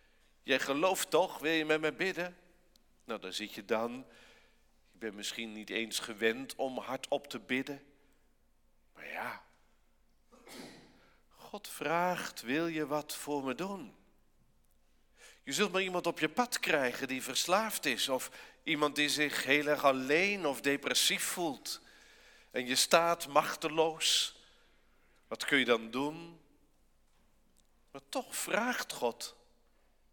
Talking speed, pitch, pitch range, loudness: 135 wpm, 145 Hz, 120-160 Hz, -33 LUFS